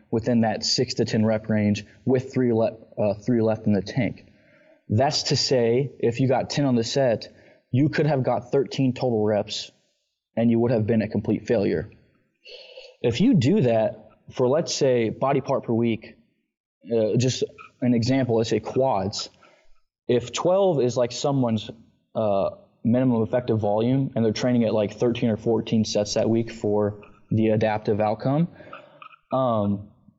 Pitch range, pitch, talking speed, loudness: 110-130 Hz, 115 Hz, 165 wpm, -23 LUFS